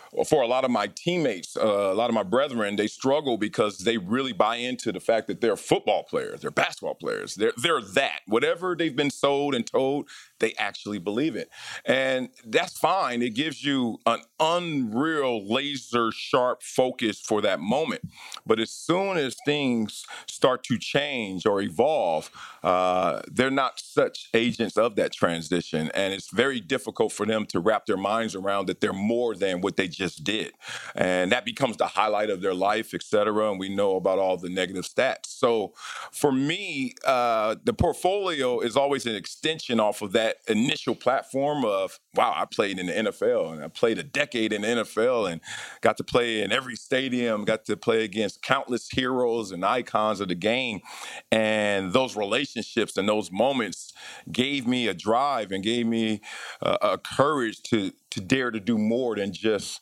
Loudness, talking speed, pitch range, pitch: -26 LUFS, 185 wpm, 105-145 Hz, 120 Hz